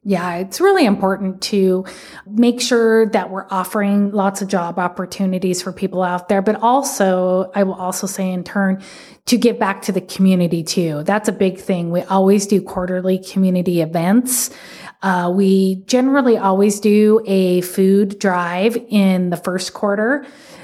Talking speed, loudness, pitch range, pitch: 160 wpm, -17 LUFS, 185-210 Hz, 195 Hz